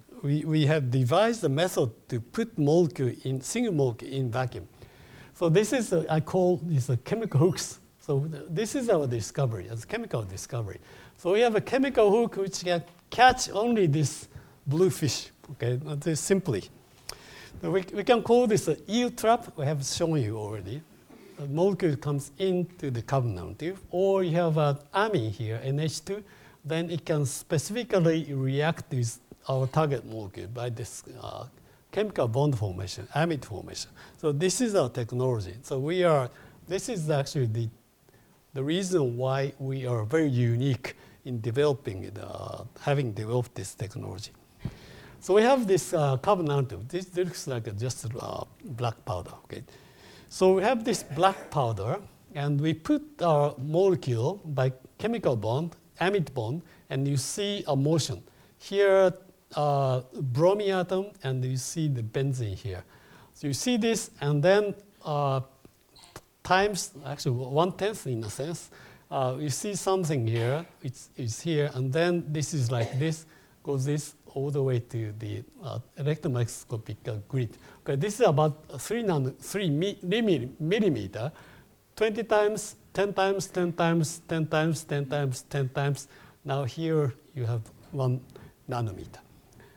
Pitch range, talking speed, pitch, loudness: 125-180 Hz, 160 wpm, 145 Hz, -28 LUFS